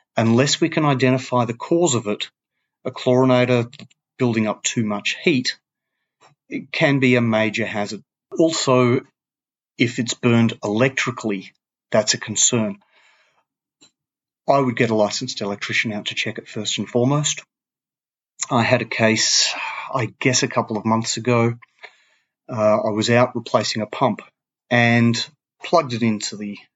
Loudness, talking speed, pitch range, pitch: -19 LUFS, 145 wpm, 110-130 Hz, 120 Hz